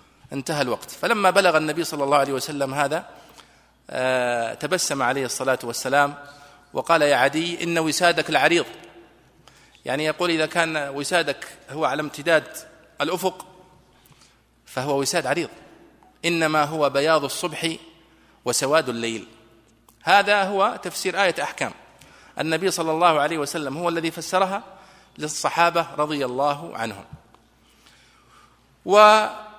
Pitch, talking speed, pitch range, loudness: 155 Hz, 115 wpm, 140-175 Hz, -22 LUFS